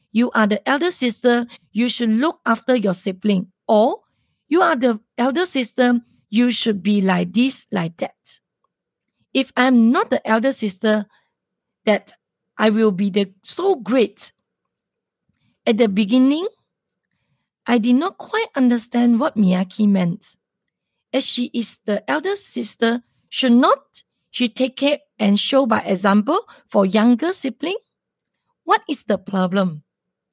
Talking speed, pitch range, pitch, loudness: 140 wpm, 210-265 Hz, 235 Hz, -19 LUFS